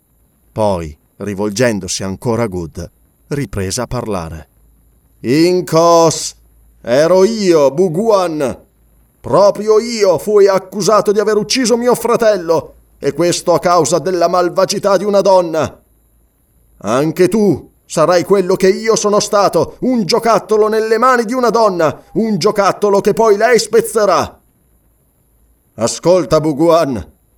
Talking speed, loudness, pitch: 115 wpm, -13 LUFS, 180 Hz